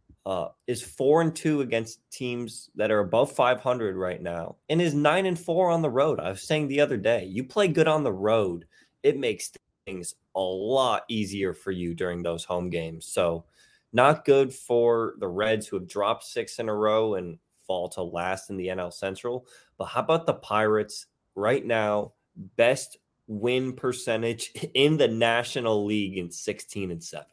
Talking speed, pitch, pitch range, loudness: 185 wpm, 115 Hz, 95-135 Hz, -26 LUFS